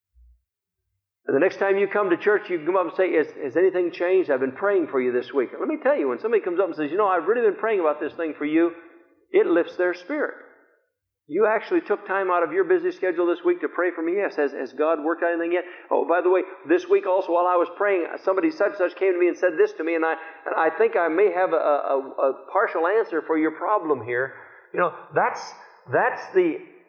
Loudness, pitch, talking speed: -23 LUFS, 185 Hz, 260 wpm